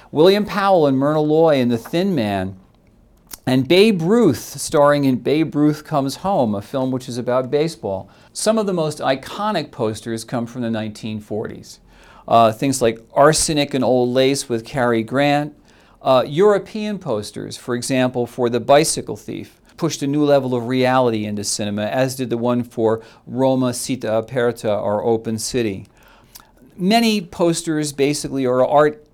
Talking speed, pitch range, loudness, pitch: 160 wpm, 115-150 Hz, -18 LUFS, 130 Hz